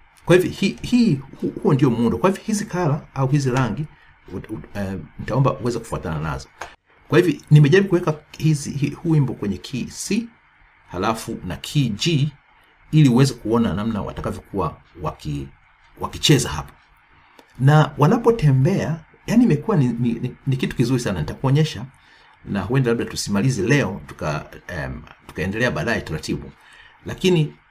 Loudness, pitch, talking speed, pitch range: -20 LUFS, 140 Hz, 130 wpm, 115-165 Hz